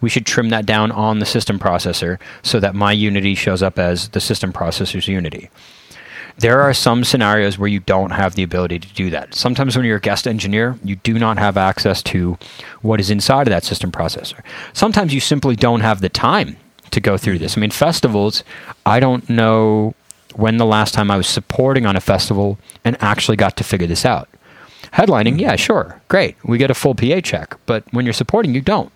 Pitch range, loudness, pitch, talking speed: 95-120 Hz, -16 LUFS, 110 Hz, 210 wpm